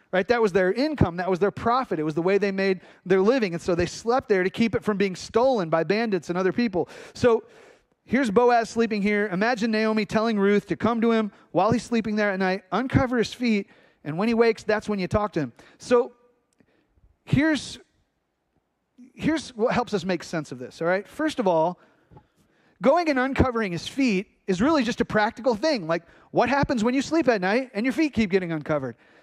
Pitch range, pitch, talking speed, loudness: 190-245 Hz, 220 Hz, 215 wpm, -24 LUFS